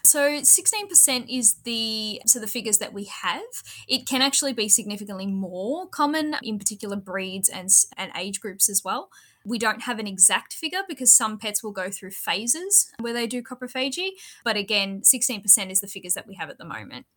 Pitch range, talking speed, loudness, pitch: 200-270 Hz, 190 wpm, -21 LUFS, 225 Hz